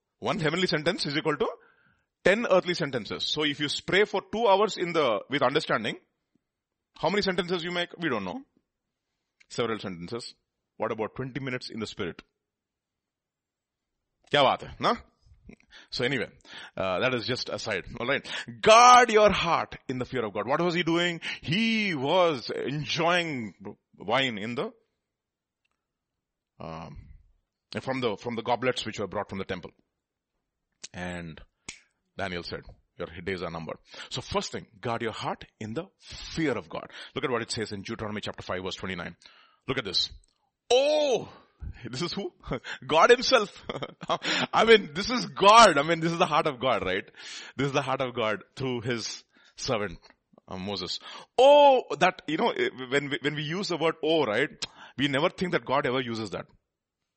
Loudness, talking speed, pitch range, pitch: -26 LUFS, 165 wpm, 110-185 Hz, 145 Hz